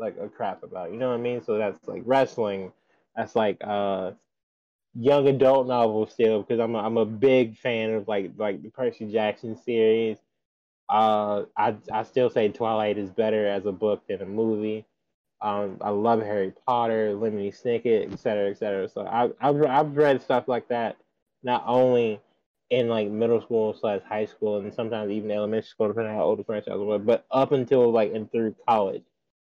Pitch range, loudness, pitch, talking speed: 105-120 Hz, -25 LUFS, 110 Hz, 195 wpm